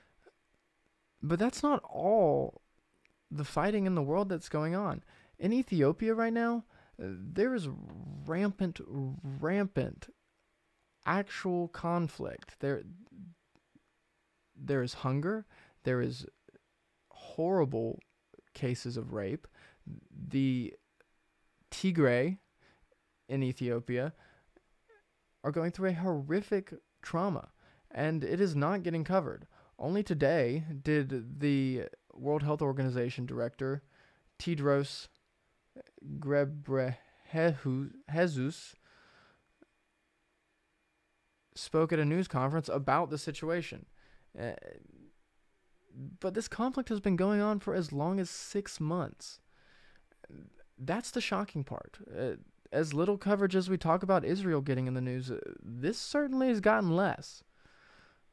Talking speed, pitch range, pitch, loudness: 105 wpm, 140-190 Hz, 160 Hz, -33 LUFS